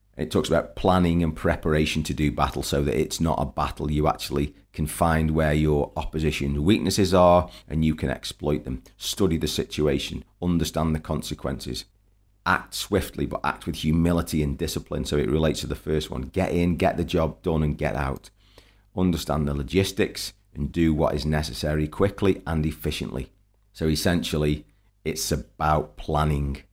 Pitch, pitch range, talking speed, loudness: 80 Hz, 75-90 Hz, 170 wpm, -25 LUFS